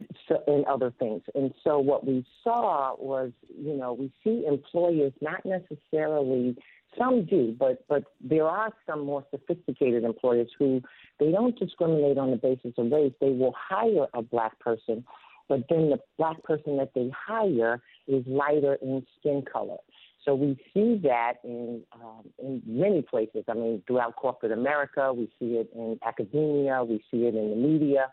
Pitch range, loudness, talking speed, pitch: 120-150 Hz, -28 LUFS, 170 wpm, 135 Hz